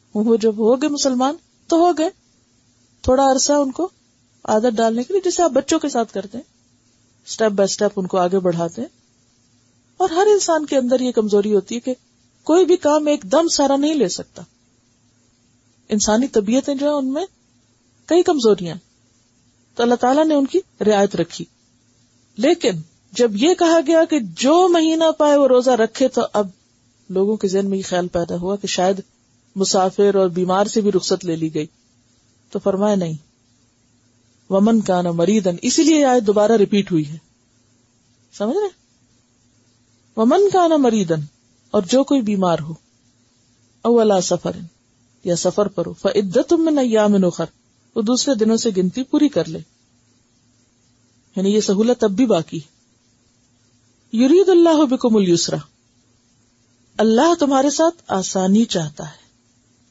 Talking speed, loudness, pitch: 160 wpm, -17 LUFS, 195 Hz